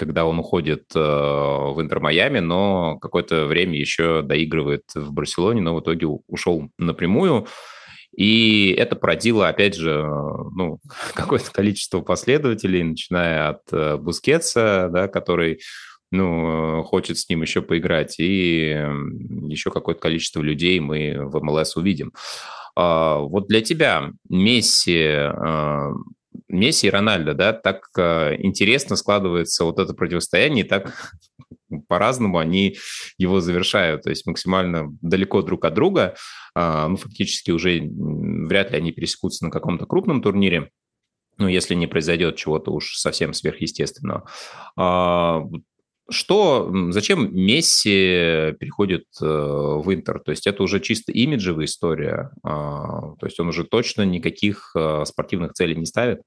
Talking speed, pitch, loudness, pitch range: 125 wpm, 85 Hz, -20 LUFS, 75-95 Hz